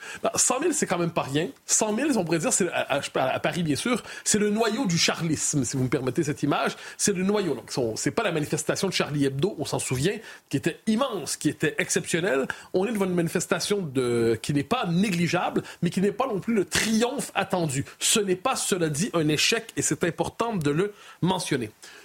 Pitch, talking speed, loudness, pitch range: 180 Hz, 215 wpm, -25 LUFS, 155-205 Hz